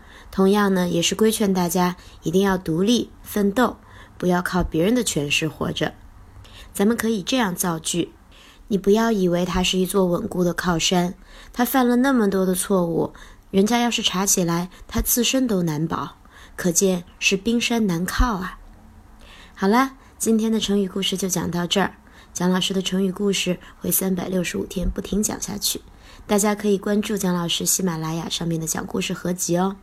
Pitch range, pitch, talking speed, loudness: 175-210 Hz, 190 Hz, 270 characters per minute, -21 LUFS